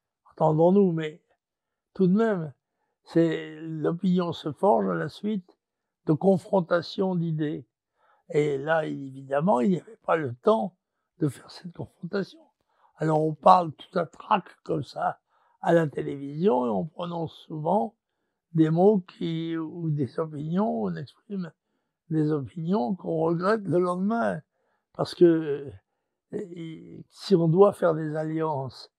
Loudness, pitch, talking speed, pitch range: -26 LUFS, 170 Hz, 140 wpm, 155-195 Hz